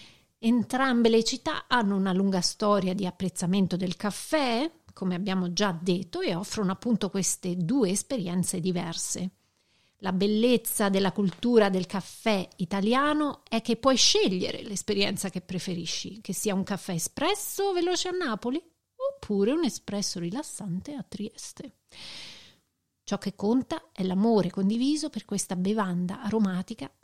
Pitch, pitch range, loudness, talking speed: 205 Hz, 185-240 Hz, -27 LUFS, 135 wpm